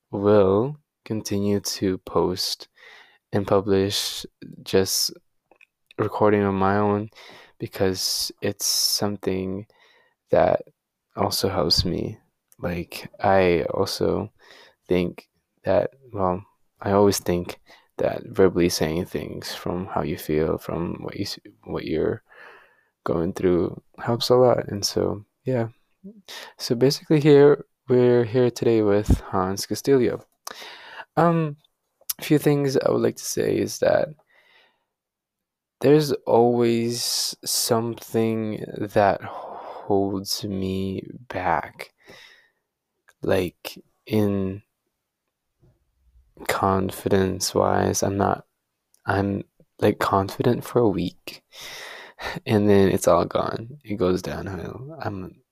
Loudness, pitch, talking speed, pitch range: -23 LUFS, 105 Hz, 105 wpm, 95-120 Hz